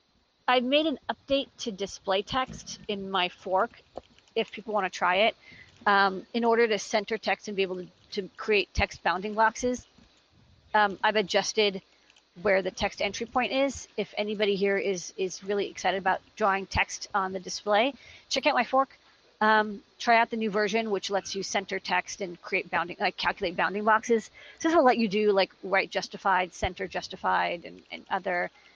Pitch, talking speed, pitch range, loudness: 205 Hz, 185 wpm, 190-225 Hz, -27 LUFS